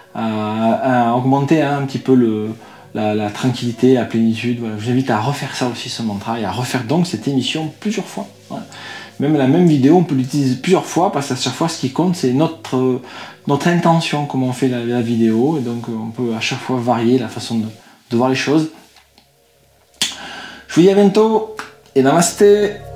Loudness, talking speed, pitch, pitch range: -16 LUFS, 210 wpm, 130 Hz, 115-145 Hz